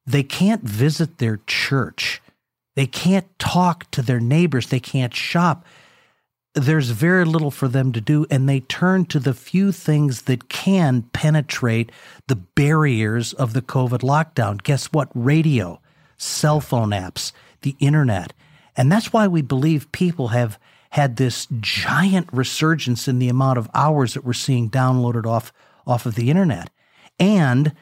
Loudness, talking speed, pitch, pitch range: -19 LUFS, 155 wpm, 135 Hz, 125-155 Hz